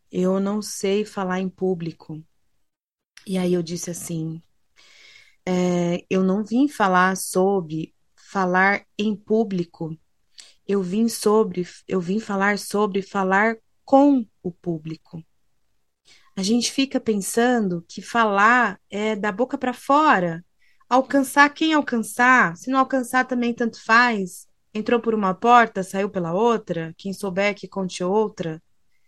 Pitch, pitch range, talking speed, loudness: 200 Hz, 185-235 Hz, 130 wpm, -21 LUFS